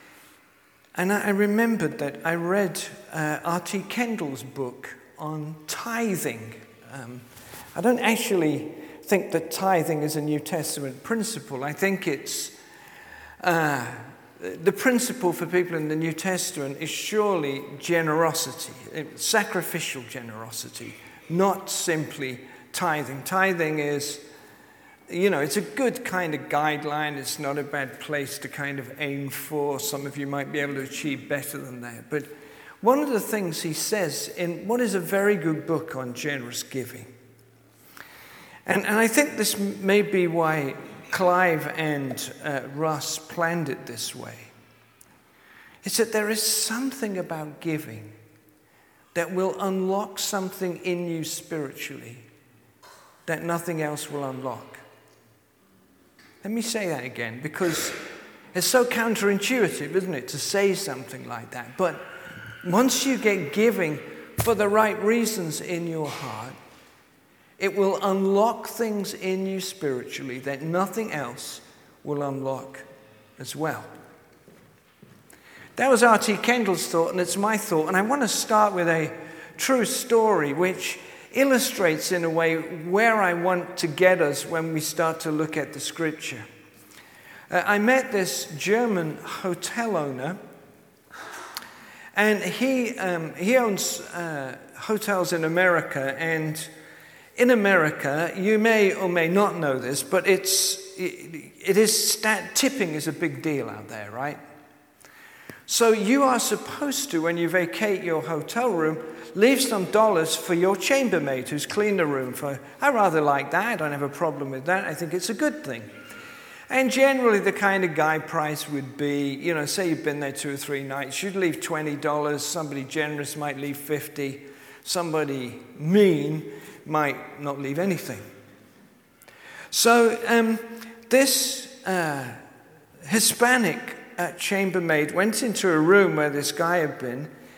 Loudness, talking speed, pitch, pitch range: -24 LUFS, 145 wpm, 165 Hz, 145-200 Hz